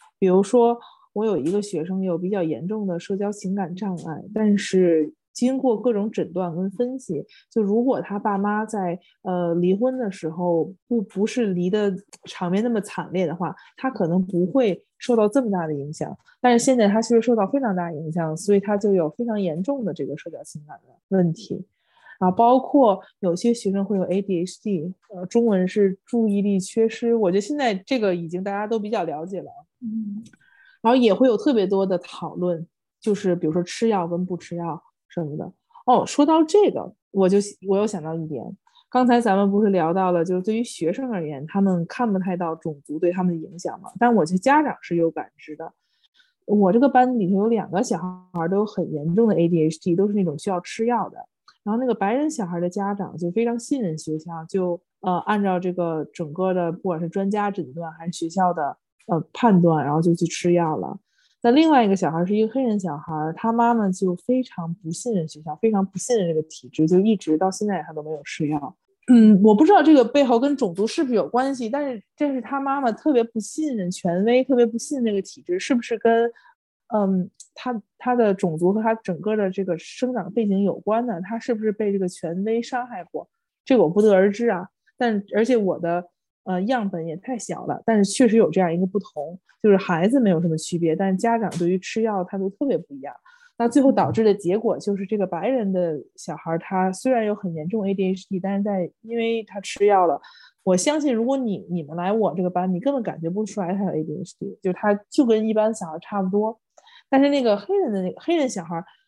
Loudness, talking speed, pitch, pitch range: -22 LUFS, 315 characters per minute, 200 Hz, 175-230 Hz